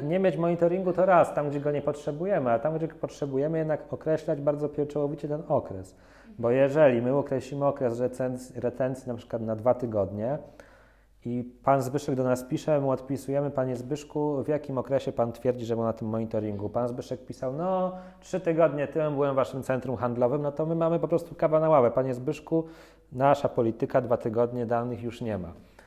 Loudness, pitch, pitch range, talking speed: -28 LUFS, 135 Hz, 125-150 Hz, 195 wpm